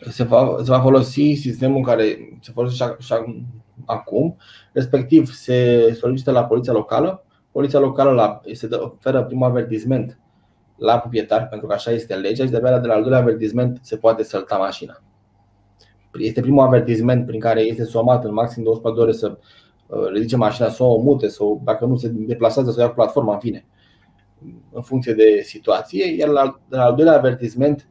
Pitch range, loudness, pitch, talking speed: 115-130 Hz, -18 LUFS, 120 Hz, 175 wpm